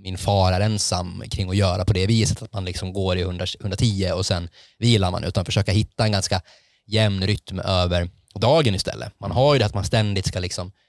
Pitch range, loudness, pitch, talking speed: 95-110 Hz, -22 LUFS, 100 Hz, 215 wpm